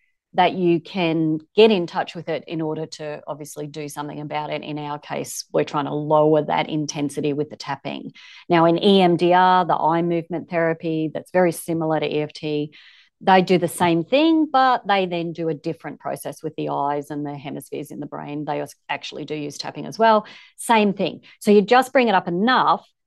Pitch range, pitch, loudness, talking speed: 150-185 Hz, 165 Hz, -21 LUFS, 200 wpm